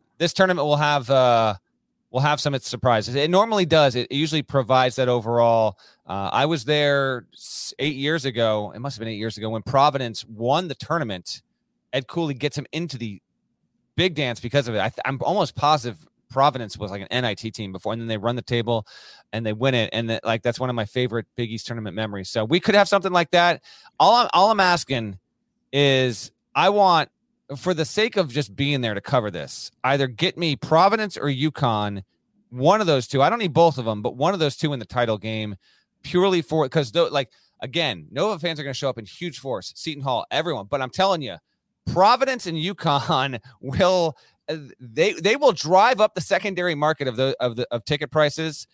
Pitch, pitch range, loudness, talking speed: 135 Hz, 115-160 Hz, -22 LUFS, 215 wpm